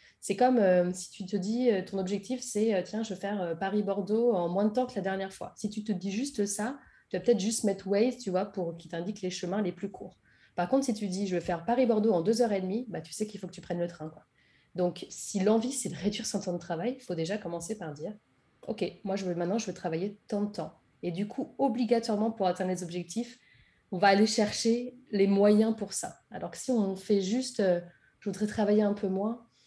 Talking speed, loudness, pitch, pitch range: 260 wpm, -30 LUFS, 200 Hz, 185-225 Hz